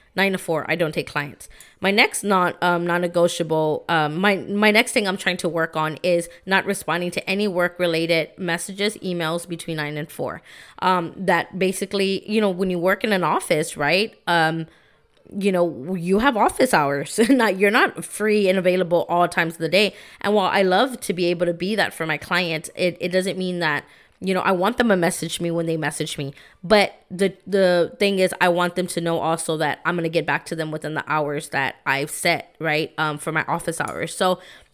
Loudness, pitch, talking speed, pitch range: -21 LUFS, 175 Hz, 220 wpm, 160-195 Hz